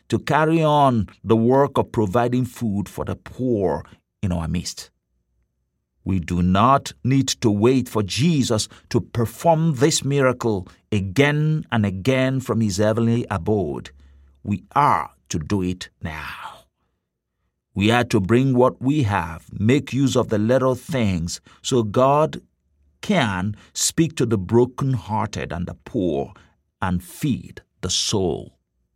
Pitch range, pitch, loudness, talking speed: 90-130 Hz, 110 Hz, -21 LUFS, 135 wpm